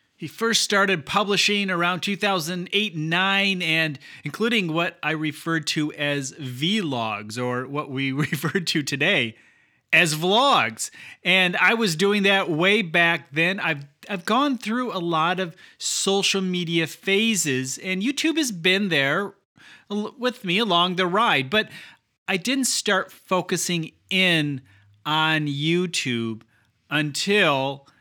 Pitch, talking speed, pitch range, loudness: 180 Hz, 130 wpm, 150-200 Hz, -22 LUFS